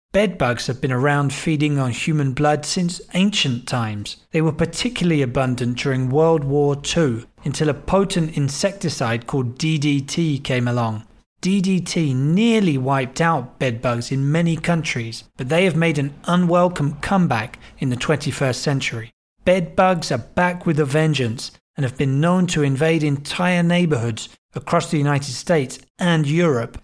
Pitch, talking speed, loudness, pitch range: 150 Hz, 155 wpm, -20 LUFS, 130-170 Hz